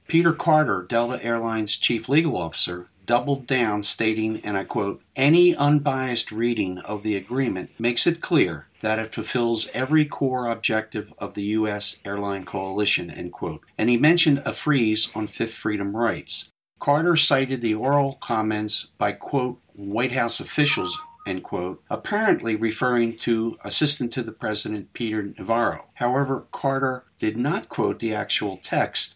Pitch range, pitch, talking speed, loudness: 110-135 Hz, 115 Hz, 150 wpm, -23 LUFS